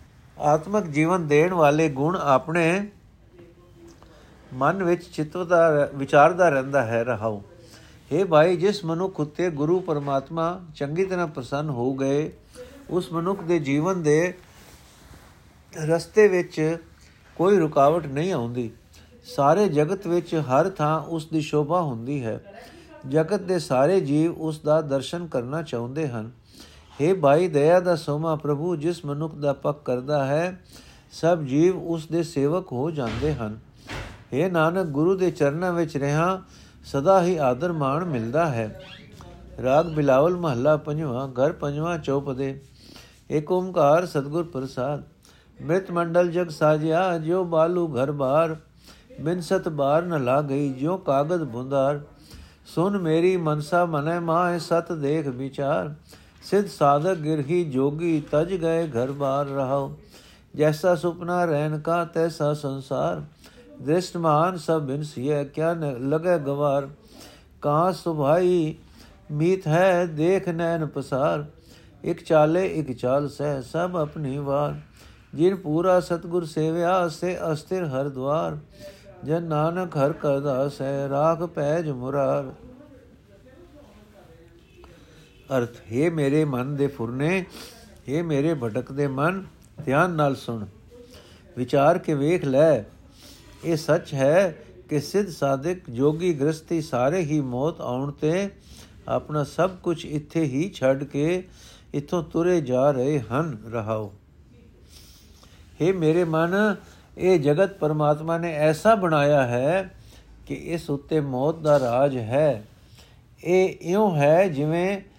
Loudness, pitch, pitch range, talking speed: -23 LUFS, 155 Hz, 140-175 Hz, 125 wpm